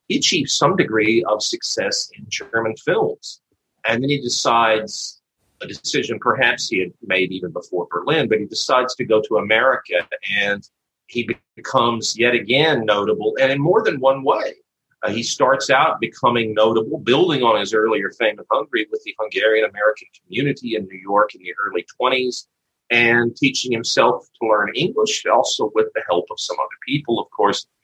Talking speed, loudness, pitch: 180 wpm, -19 LUFS, 120 Hz